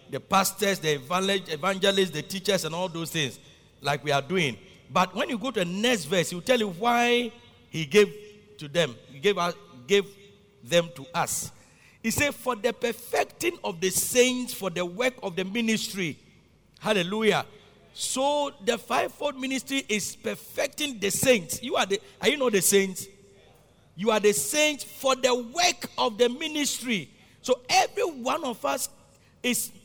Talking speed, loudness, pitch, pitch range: 170 wpm, -26 LUFS, 200 Hz, 175-245 Hz